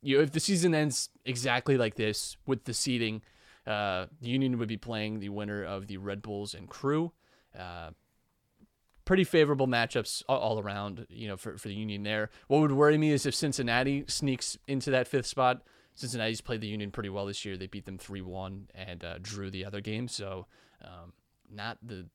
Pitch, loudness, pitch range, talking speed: 110 Hz, -31 LUFS, 100-135 Hz, 200 wpm